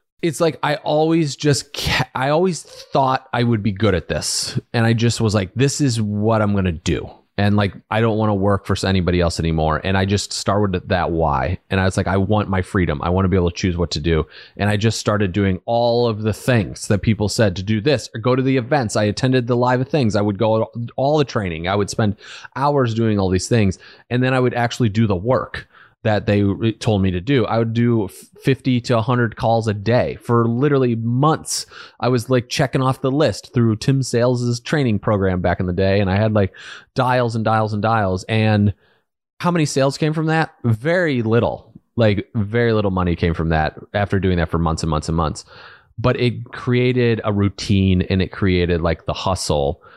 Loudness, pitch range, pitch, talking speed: -19 LUFS, 95-125 Hz, 110 Hz, 225 wpm